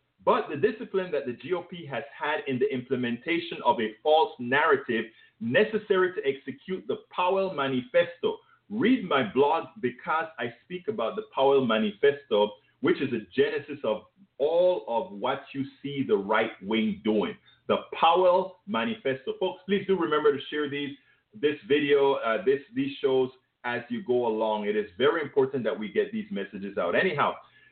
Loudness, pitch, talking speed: -27 LUFS, 180 Hz, 165 wpm